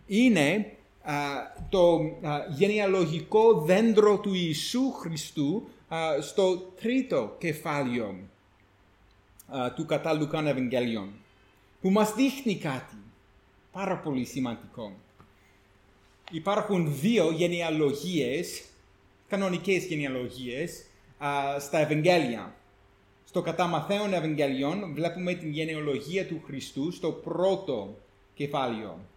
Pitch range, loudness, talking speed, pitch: 110-180 Hz, -28 LUFS, 85 wpm, 150 Hz